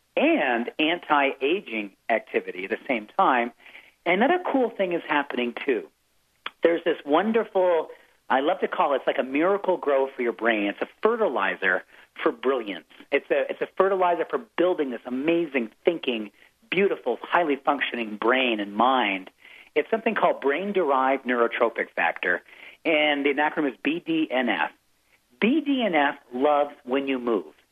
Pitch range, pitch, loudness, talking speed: 130-210 Hz, 150 Hz, -24 LUFS, 145 wpm